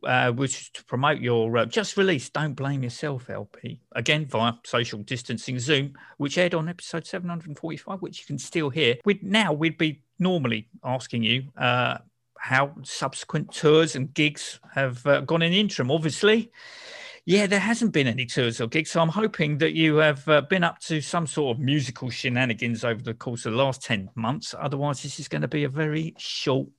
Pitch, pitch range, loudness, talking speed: 150 Hz, 125-165 Hz, -25 LUFS, 195 wpm